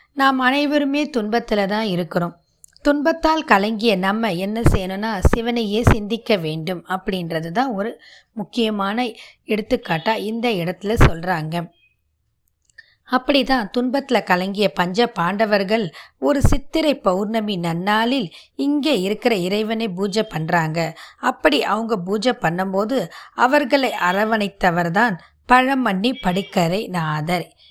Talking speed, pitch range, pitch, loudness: 95 wpm, 185-245 Hz, 215 Hz, -20 LUFS